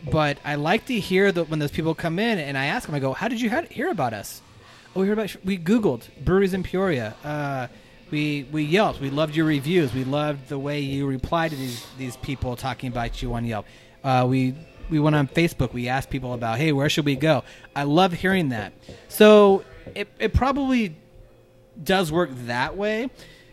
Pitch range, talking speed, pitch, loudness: 130-185 Hz, 210 wpm, 150 Hz, -23 LUFS